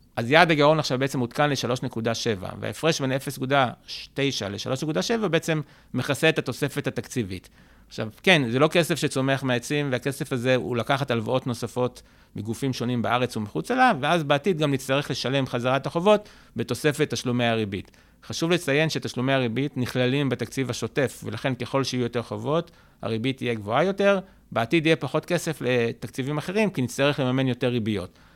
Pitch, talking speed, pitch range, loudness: 130 Hz, 150 wpm, 120-150 Hz, -25 LUFS